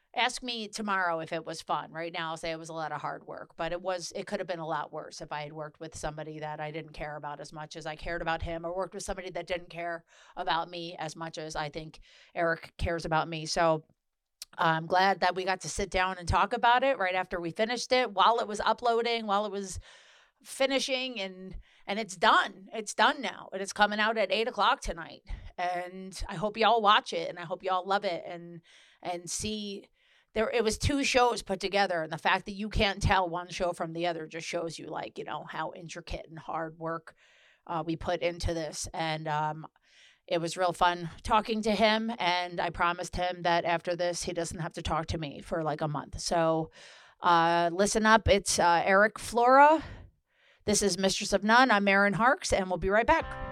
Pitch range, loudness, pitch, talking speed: 165-205 Hz, -29 LUFS, 180 Hz, 230 wpm